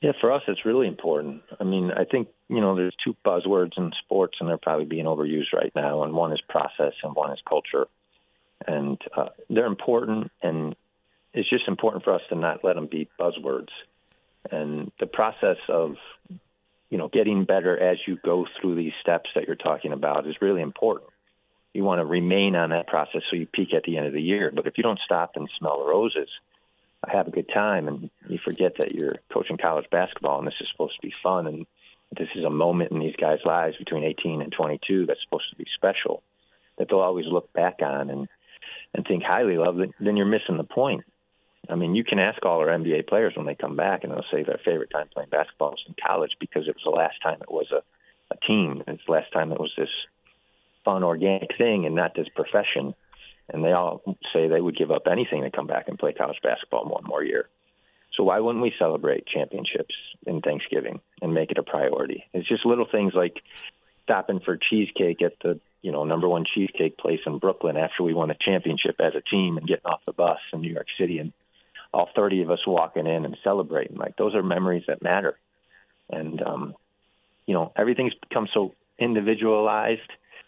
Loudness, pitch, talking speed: -25 LUFS, 100 Hz, 215 wpm